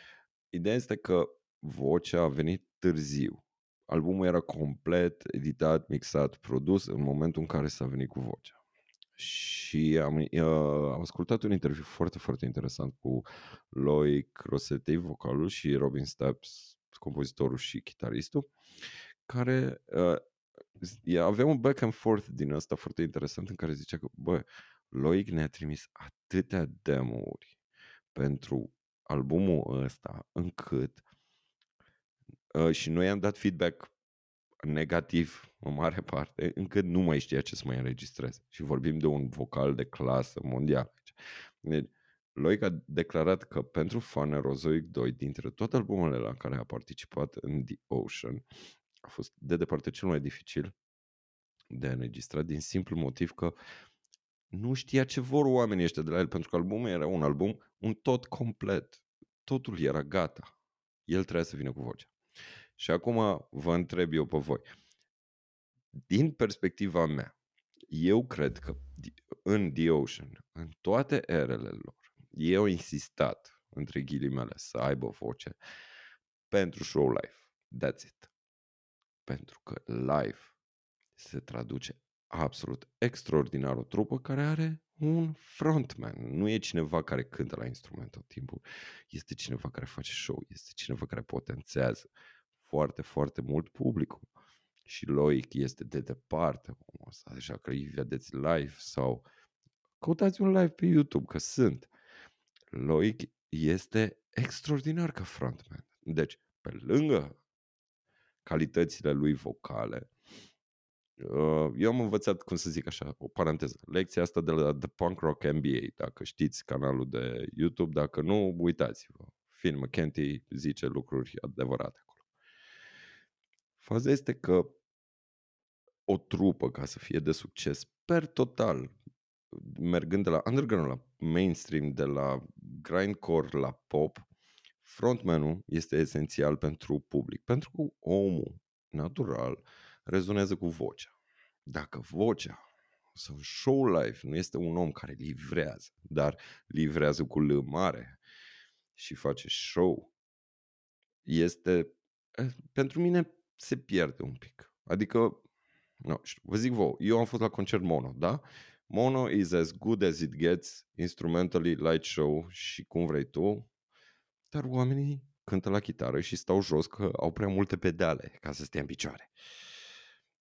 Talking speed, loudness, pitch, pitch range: 135 wpm, -32 LUFS, 80 Hz, 70-100 Hz